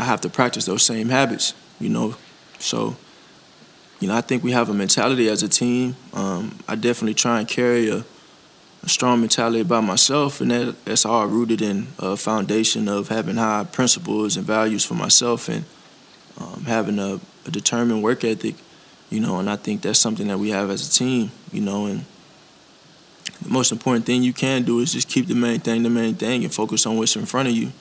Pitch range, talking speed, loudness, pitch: 105-120 Hz, 210 wpm, -20 LUFS, 115 Hz